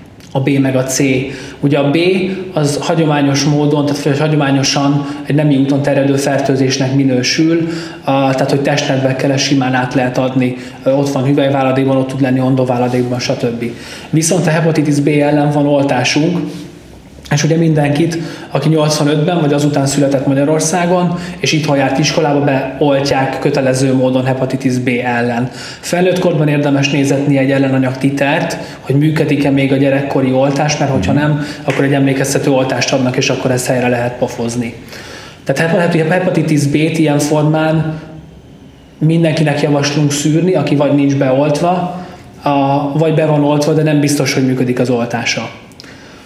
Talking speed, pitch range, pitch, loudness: 145 wpm, 130-155 Hz, 140 Hz, -13 LUFS